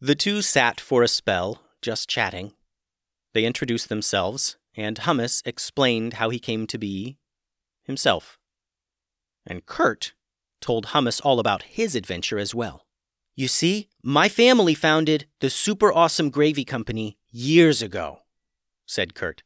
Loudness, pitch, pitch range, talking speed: -22 LUFS, 120 Hz, 110-150 Hz, 135 wpm